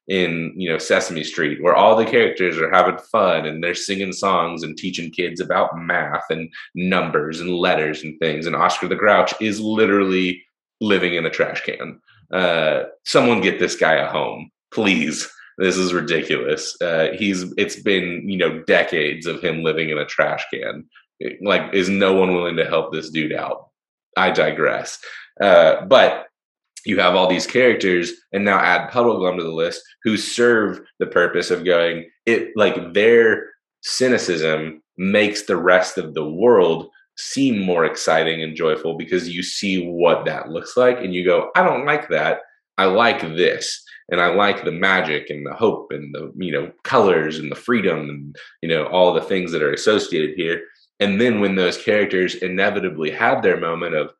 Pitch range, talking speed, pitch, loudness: 85-125 Hz, 180 wpm, 95 Hz, -18 LUFS